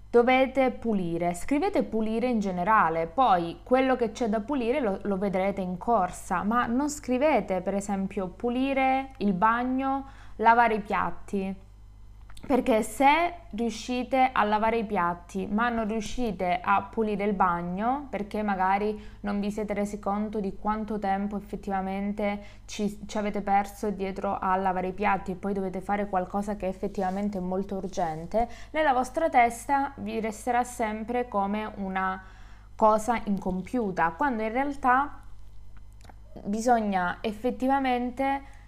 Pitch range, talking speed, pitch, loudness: 195-240 Hz, 135 wpm, 210 Hz, -27 LUFS